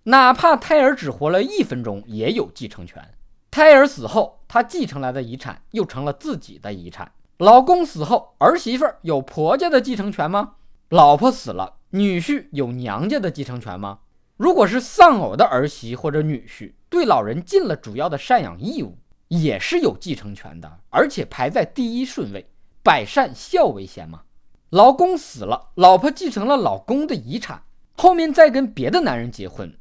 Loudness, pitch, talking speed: -17 LUFS, 180 Hz, 265 characters per minute